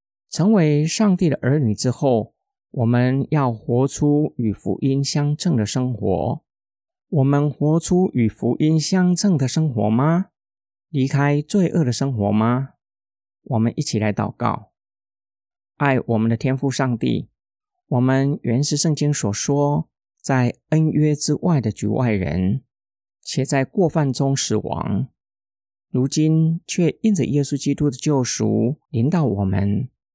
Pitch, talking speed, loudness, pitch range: 135 Hz, 195 characters per minute, -20 LUFS, 115-155 Hz